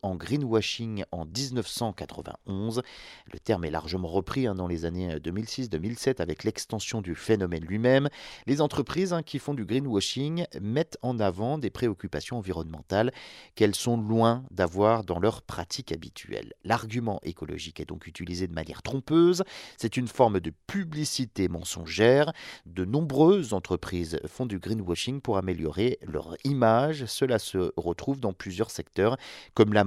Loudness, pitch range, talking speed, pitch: -28 LUFS, 90-130 Hz, 140 wpm, 110 Hz